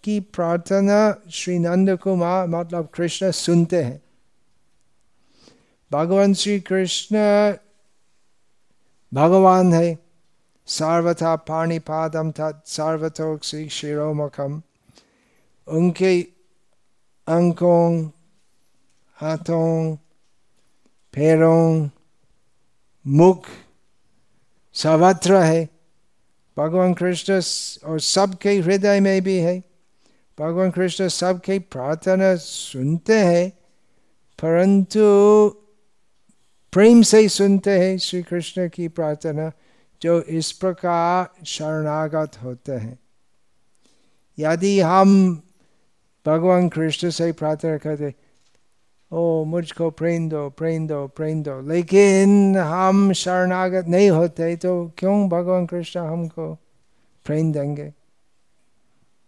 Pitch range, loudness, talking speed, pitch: 155-185 Hz, -19 LUFS, 85 wpm, 170 Hz